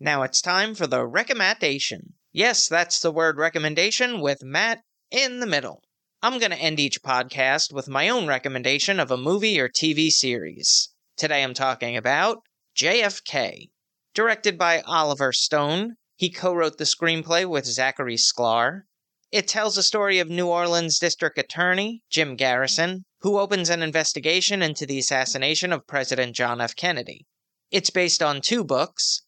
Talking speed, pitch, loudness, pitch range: 160 wpm, 160 Hz, -22 LUFS, 135-185 Hz